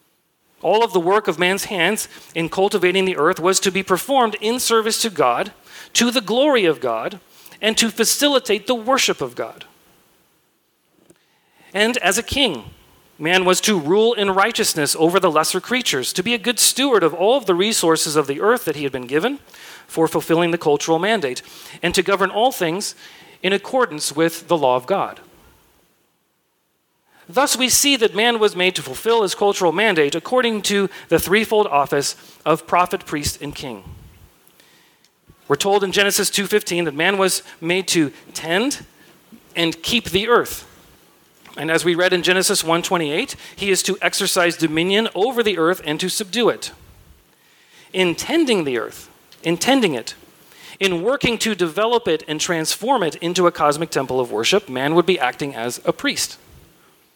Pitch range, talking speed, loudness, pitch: 165-220 Hz, 170 wpm, -18 LUFS, 185 Hz